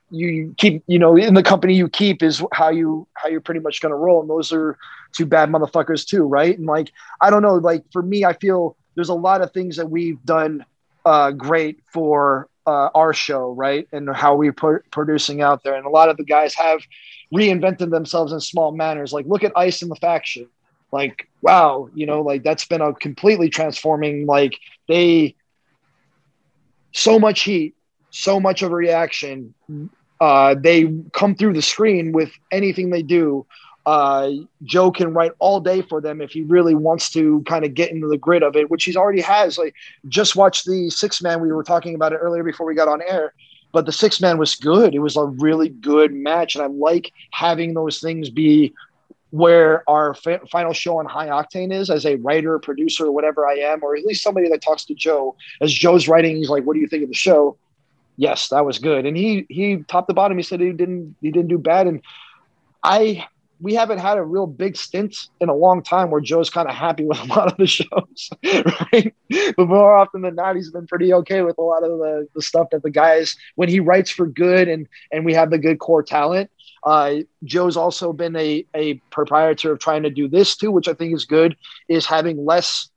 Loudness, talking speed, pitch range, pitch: -17 LUFS, 220 wpm, 150-180 Hz, 160 Hz